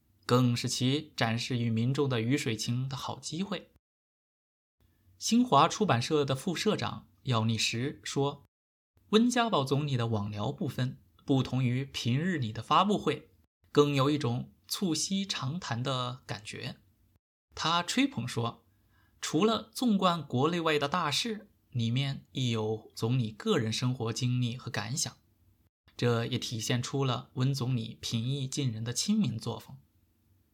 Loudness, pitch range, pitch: -30 LUFS, 110-145 Hz, 125 Hz